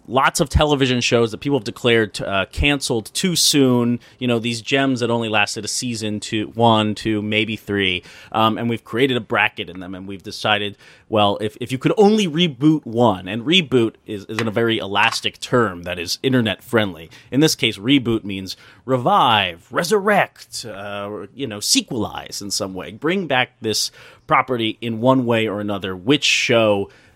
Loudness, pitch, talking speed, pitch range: -19 LUFS, 115 Hz, 185 wpm, 105-130 Hz